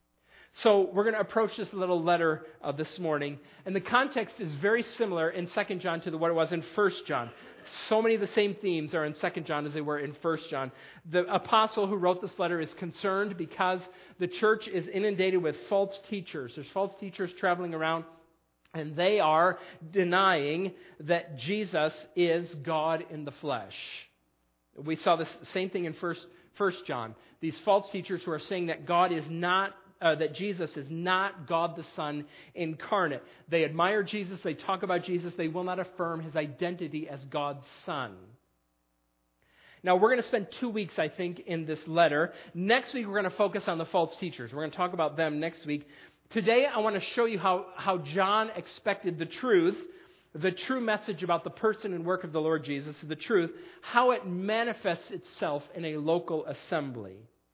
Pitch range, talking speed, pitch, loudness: 160-195 Hz, 190 wpm, 175 Hz, -30 LUFS